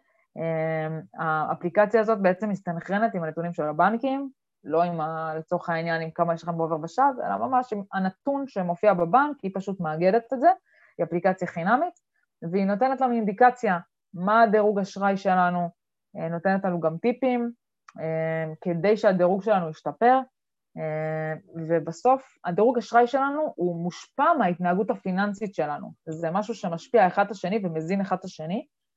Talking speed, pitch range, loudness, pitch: 140 wpm, 165-230 Hz, -25 LUFS, 190 Hz